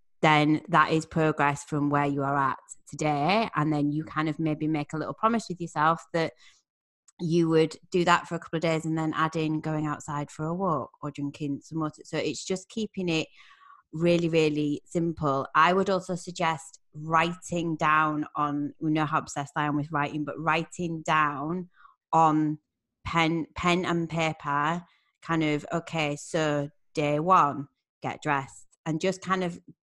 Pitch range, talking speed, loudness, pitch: 150-170 Hz, 175 wpm, -27 LUFS, 155 Hz